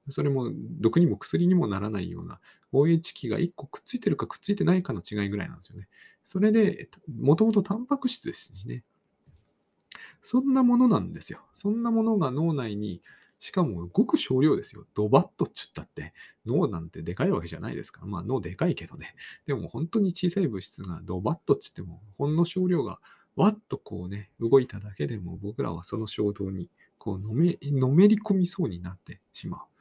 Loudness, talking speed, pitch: -27 LUFS, 395 characters per minute, 145 Hz